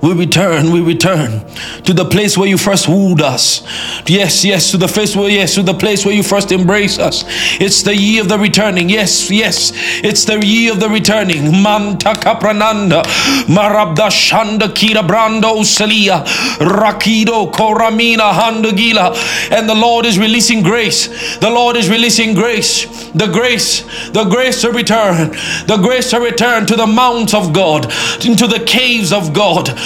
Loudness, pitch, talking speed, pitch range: -10 LUFS, 210 Hz, 155 wpm, 185-225 Hz